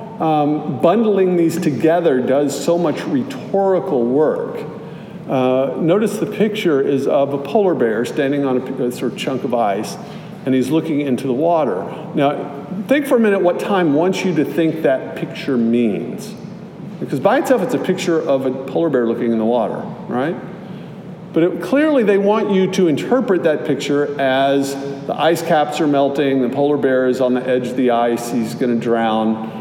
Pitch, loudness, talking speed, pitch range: 155 Hz, -17 LUFS, 185 wpm, 135-190 Hz